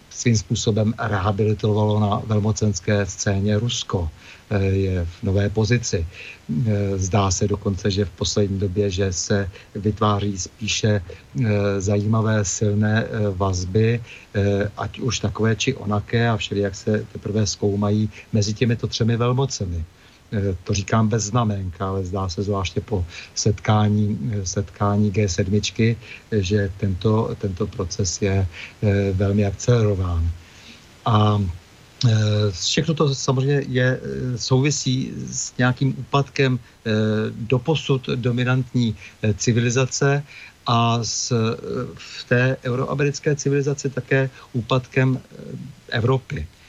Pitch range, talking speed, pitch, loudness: 100-120 Hz, 100 wpm, 105 Hz, -22 LUFS